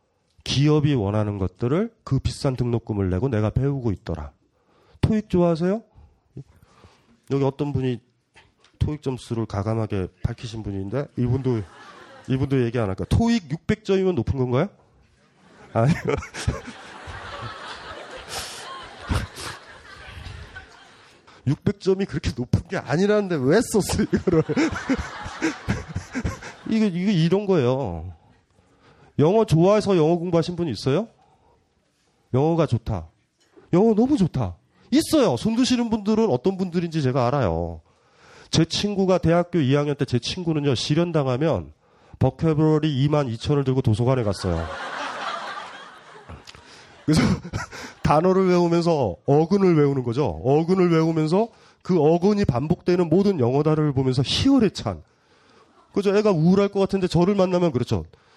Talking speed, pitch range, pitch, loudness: 265 characters per minute, 120-185 Hz, 150 Hz, -22 LUFS